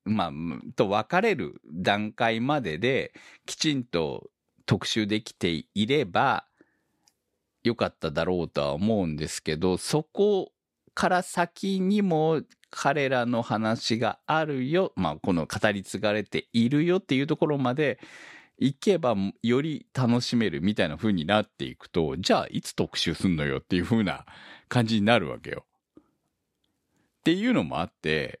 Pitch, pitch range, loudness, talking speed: 120 Hz, 105-155 Hz, -26 LUFS, 285 characters per minute